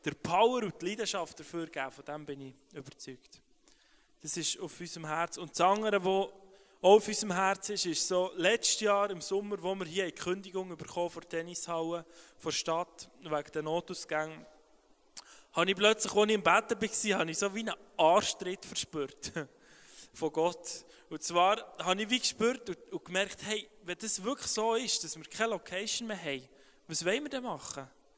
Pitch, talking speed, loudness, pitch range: 180 Hz, 190 wpm, -32 LUFS, 160-210 Hz